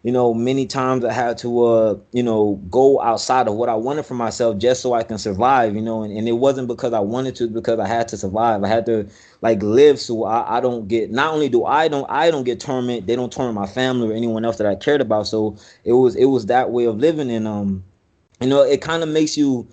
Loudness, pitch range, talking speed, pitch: -18 LUFS, 110-130 Hz, 265 wpm, 120 Hz